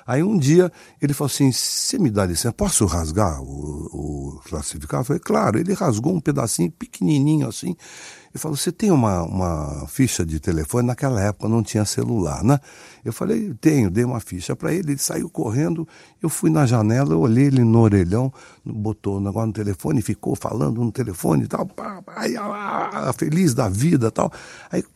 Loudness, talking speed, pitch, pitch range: -21 LUFS, 190 wpm, 120 Hz, 100-150 Hz